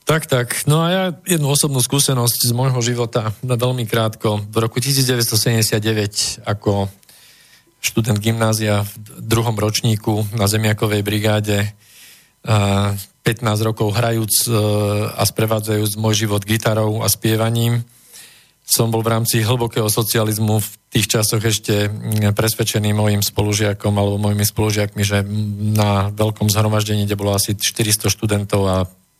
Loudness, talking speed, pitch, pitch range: -17 LUFS, 125 wpm, 110 Hz, 105-115 Hz